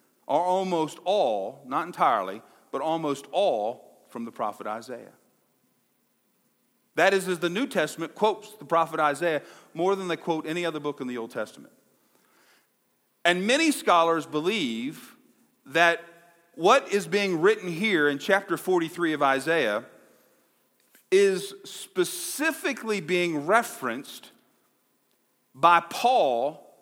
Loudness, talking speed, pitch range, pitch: -25 LUFS, 120 wpm, 160-220 Hz, 175 Hz